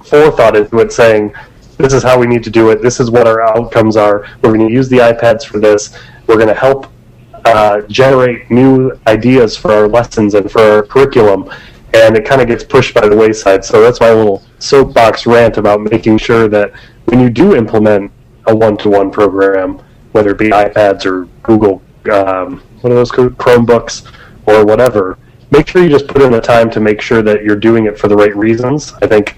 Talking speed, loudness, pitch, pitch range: 205 wpm, -8 LUFS, 115 Hz, 105-125 Hz